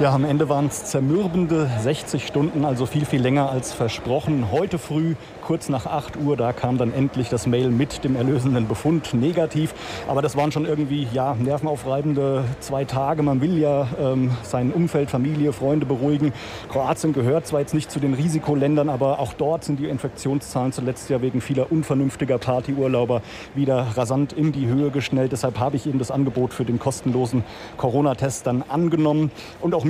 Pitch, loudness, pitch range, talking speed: 140 Hz, -22 LUFS, 130-150 Hz, 180 wpm